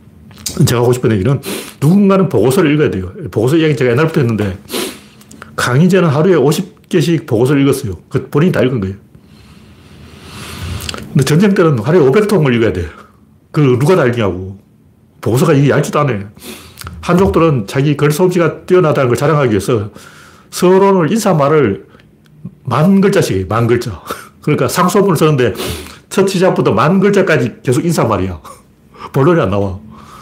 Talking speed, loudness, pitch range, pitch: 340 characters per minute, -12 LUFS, 110-175 Hz, 145 Hz